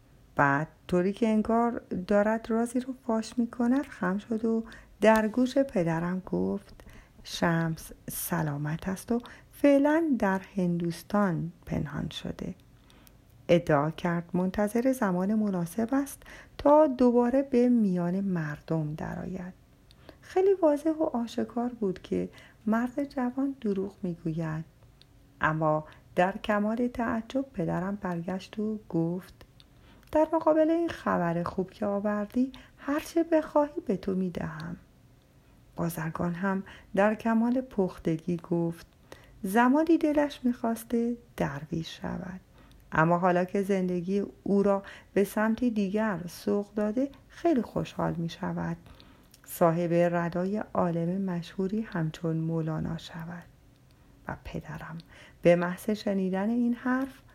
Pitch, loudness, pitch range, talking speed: 195 Hz, -29 LUFS, 170-235 Hz, 115 wpm